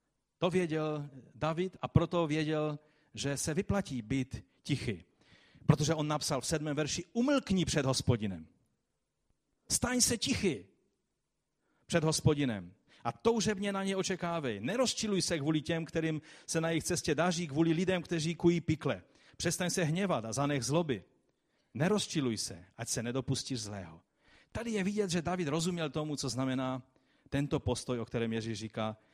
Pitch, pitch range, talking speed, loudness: 155 Hz, 130-175 Hz, 150 wpm, -33 LUFS